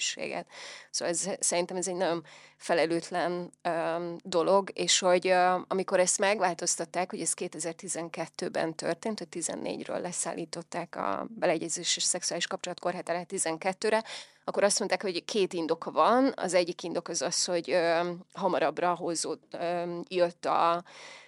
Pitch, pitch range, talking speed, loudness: 175 Hz, 170-185 Hz, 135 wpm, -29 LUFS